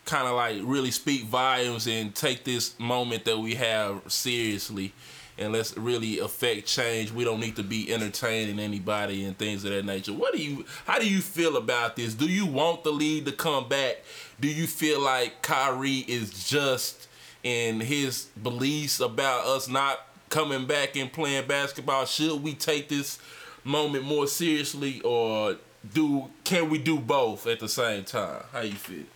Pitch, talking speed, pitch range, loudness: 130 Hz, 175 wpm, 110-145 Hz, -27 LUFS